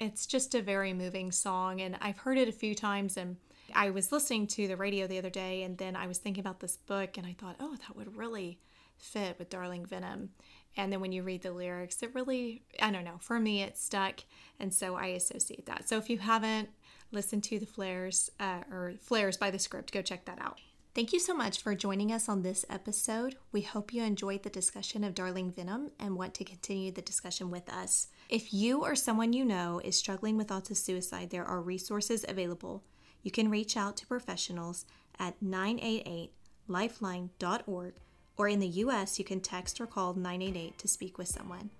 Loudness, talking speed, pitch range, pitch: -35 LUFS, 210 wpm, 185-215 Hz, 195 Hz